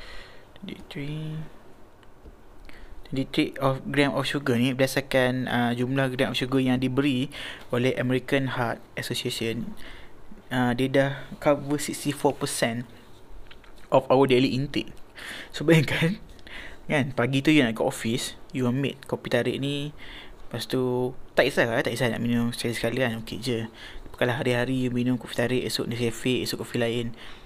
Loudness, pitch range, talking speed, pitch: -26 LUFS, 120-140 Hz, 145 wpm, 130 Hz